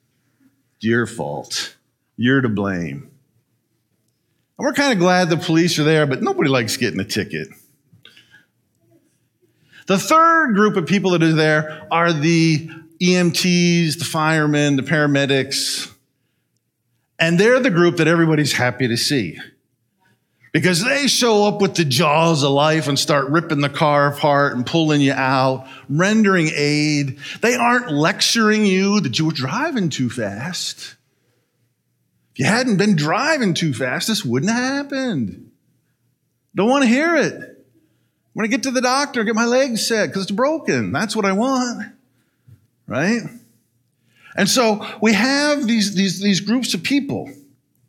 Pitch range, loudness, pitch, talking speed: 135-215 Hz, -17 LUFS, 165 Hz, 150 wpm